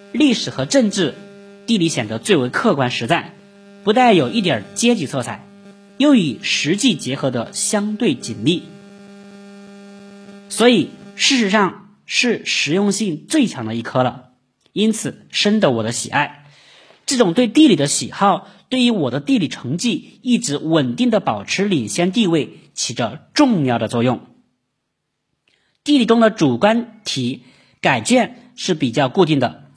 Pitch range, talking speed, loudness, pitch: 145-230 Hz, 215 characters per minute, -17 LUFS, 200 Hz